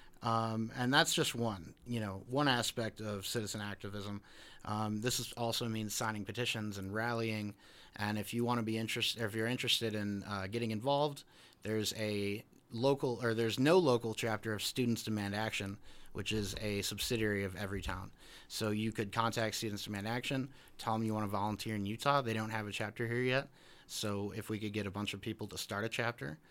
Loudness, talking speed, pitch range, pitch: -36 LUFS, 200 wpm, 105-120 Hz, 110 Hz